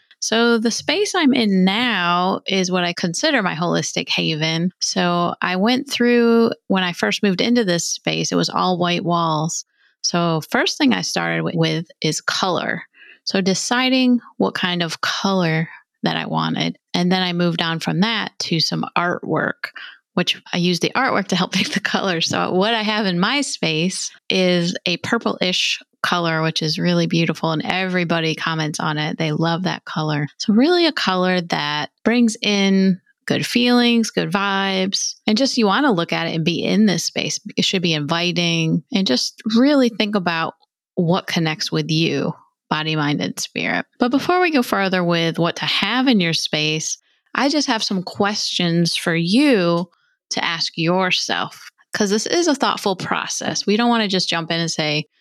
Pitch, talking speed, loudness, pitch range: 185 Hz, 185 wpm, -19 LUFS, 165-225 Hz